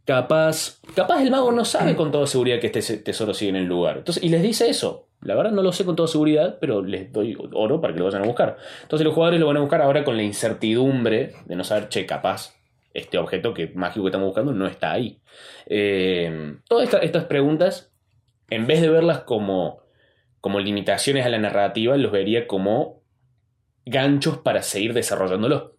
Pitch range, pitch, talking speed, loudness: 105-160 Hz, 130 Hz, 200 wpm, -21 LUFS